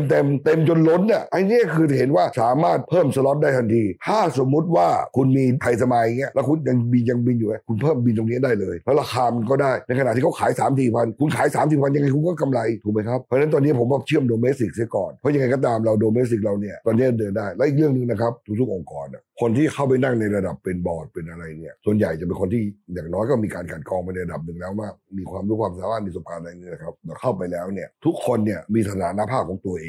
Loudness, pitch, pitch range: -21 LUFS, 120 Hz, 105-135 Hz